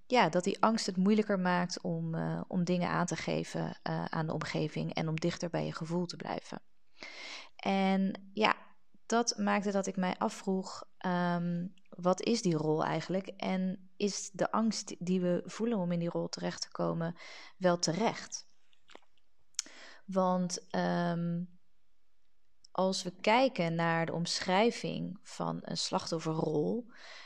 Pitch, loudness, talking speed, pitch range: 180 Hz, -33 LUFS, 150 wpm, 170-200 Hz